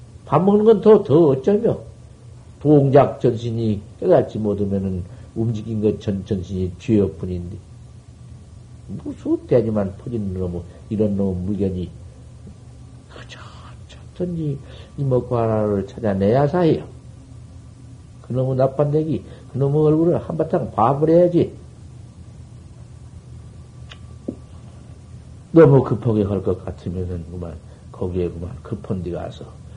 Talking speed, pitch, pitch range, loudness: 220 characters per minute, 115 Hz, 100-130 Hz, -19 LUFS